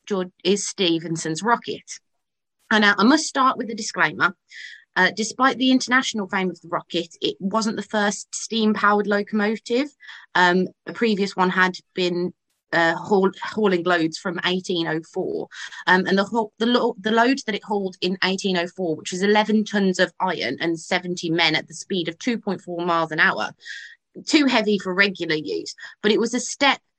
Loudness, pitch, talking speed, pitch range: -21 LUFS, 195 Hz, 170 wpm, 175-220 Hz